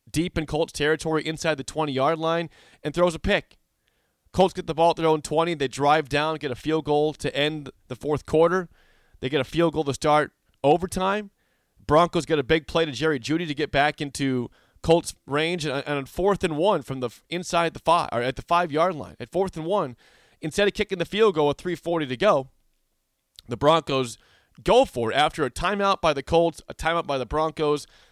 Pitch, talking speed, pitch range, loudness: 155 Hz, 210 wpm, 145-170 Hz, -24 LUFS